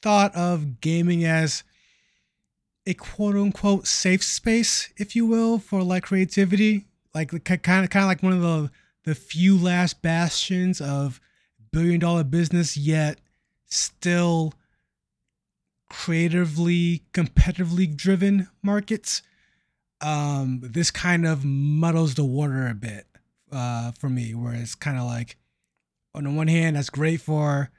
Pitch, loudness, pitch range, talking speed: 165 Hz, -23 LUFS, 145-185 Hz, 135 wpm